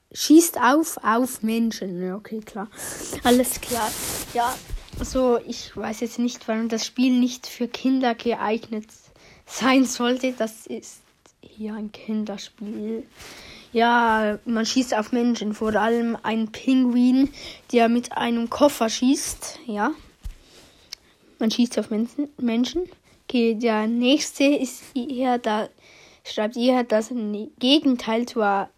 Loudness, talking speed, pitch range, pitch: -23 LUFS, 125 wpm, 220-255 Hz, 235 Hz